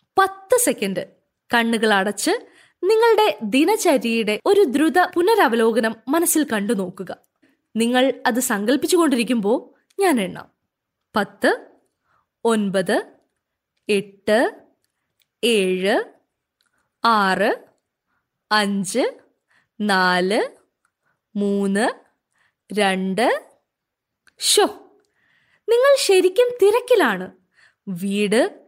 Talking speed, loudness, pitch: 65 wpm, -19 LUFS, 245 Hz